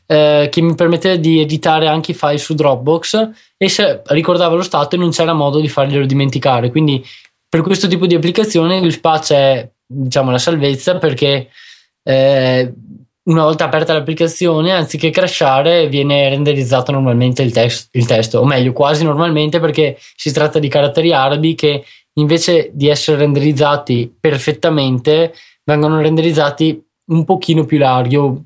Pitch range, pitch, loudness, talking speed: 140-165 Hz, 150 Hz, -13 LUFS, 150 wpm